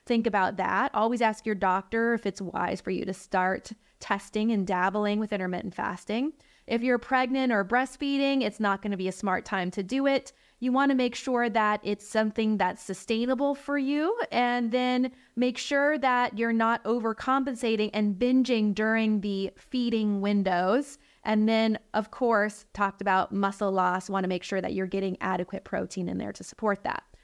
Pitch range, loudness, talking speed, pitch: 195-245 Hz, -27 LUFS, 185 wpm, 220 Hz